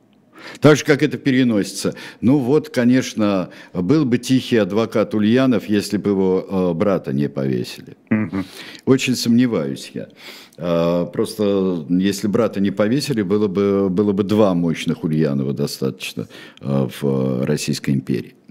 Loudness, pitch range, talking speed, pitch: -19 LUFS, 80-115 Hz, 125 wpm, 100 Hz